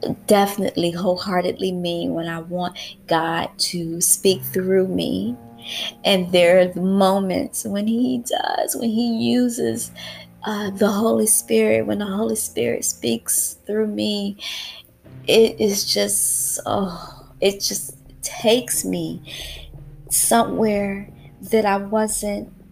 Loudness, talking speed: -20 LUFS, 120 wpm